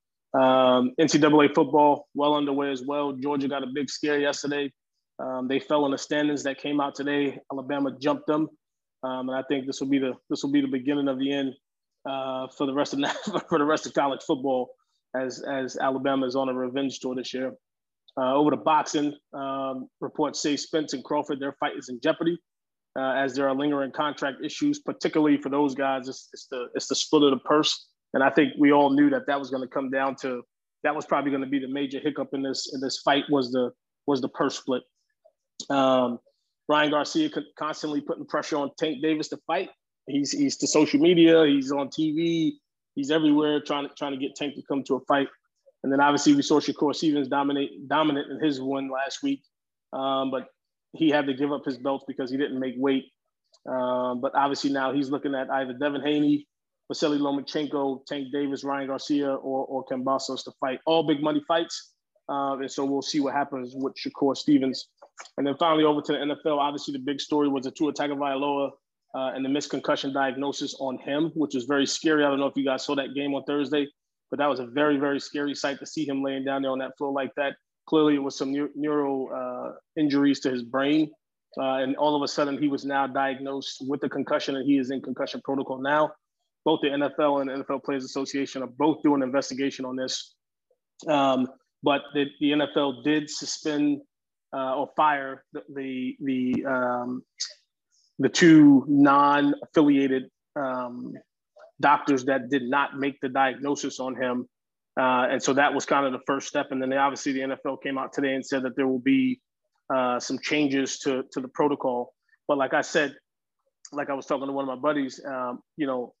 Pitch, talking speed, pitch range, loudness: 140 Hz, 210 wpm, 135-150 Hz, -26 LUFS